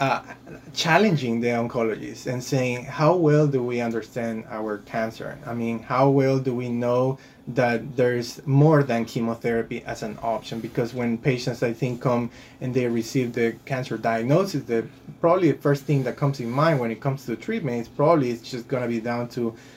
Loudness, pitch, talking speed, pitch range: -24 LUFS, 125 Hz, 190 wpm, 115-135 Hz